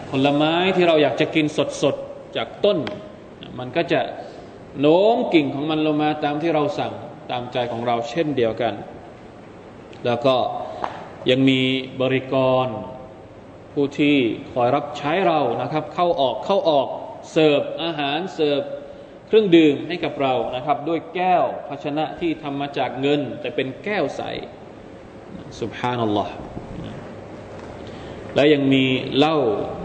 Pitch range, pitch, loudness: 130-155 Hz, 145 Hz, -21 LUFS